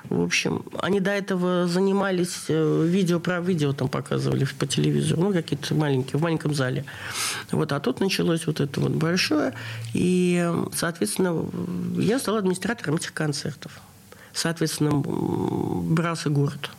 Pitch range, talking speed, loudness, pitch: 145-180 Hz, 130 wpm, -24 LUFS, 165 Hz